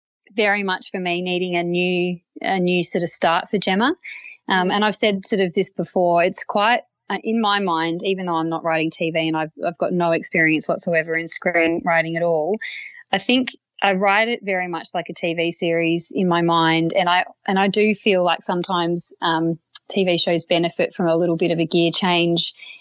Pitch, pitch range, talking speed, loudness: 175 Hz, 165-195 Hz, 210 wpm, -20 LUFS